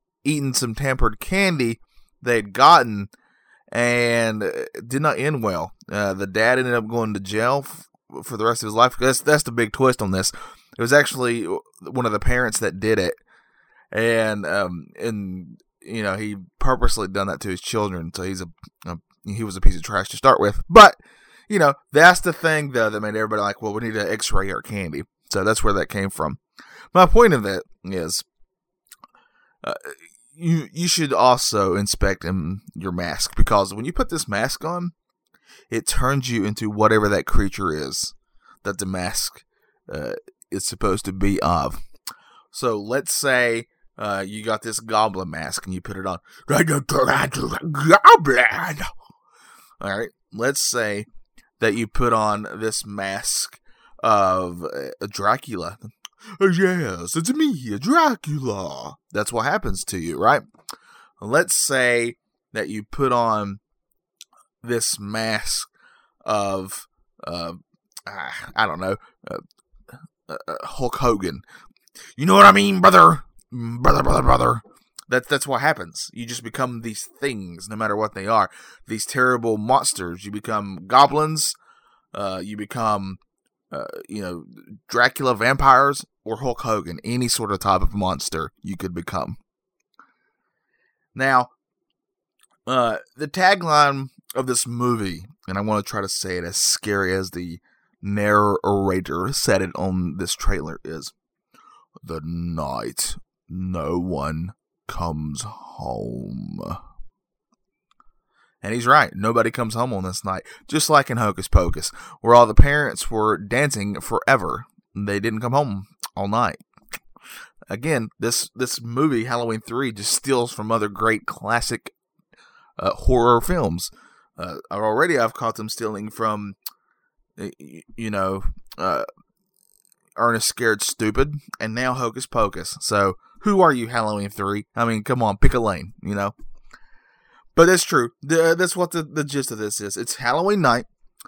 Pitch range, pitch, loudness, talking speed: 100-130 Hz, 110 Hz, -20 LUFS, 150 wpm